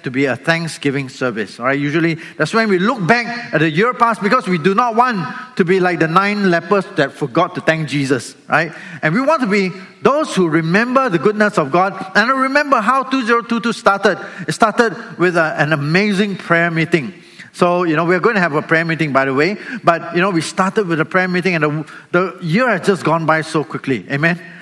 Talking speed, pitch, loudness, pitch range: 230 wpm, 180 Hz, -16 LUFS, 160-210 Hz